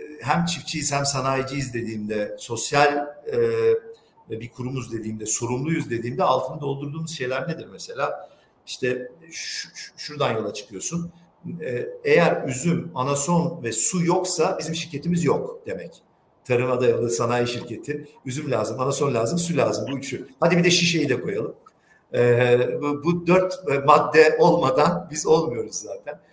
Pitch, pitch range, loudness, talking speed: 145 Hz, 125-170 Hz, -22 LUFS, 125 wpm